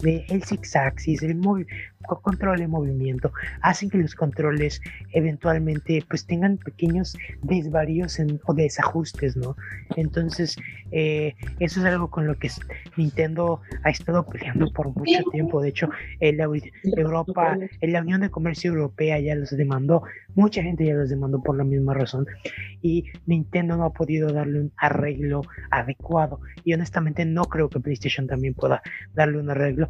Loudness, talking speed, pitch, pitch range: -24 LUFS, 160 wpm, 155 Hz, 145-170 Hz